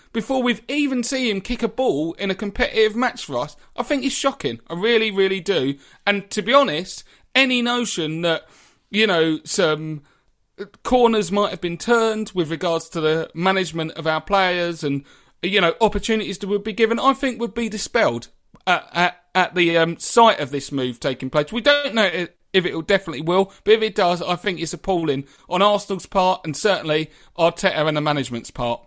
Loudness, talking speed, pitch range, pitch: -20 LUFS, 195 wpm, 160-220 Hz, 190 Hz